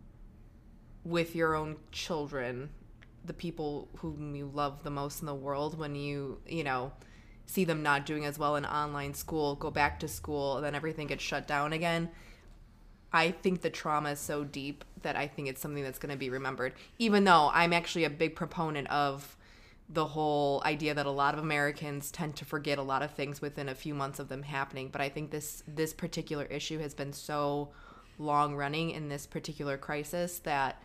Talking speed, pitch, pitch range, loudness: 200 wpm, 145 Hz, 140-155 Hz, -33 LUFS